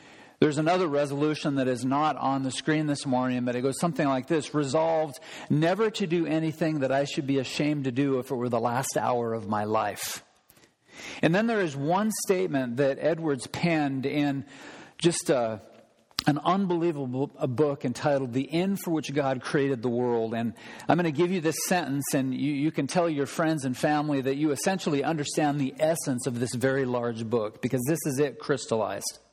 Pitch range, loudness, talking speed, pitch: 130-160 Hz, -27 LUFS, 195 wpm, 145 Hz